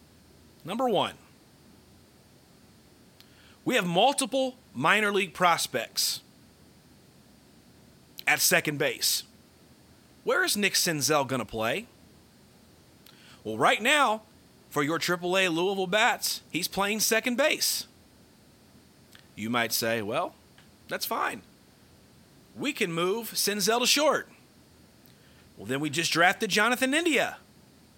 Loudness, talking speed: -26 LUFS, 105 wpm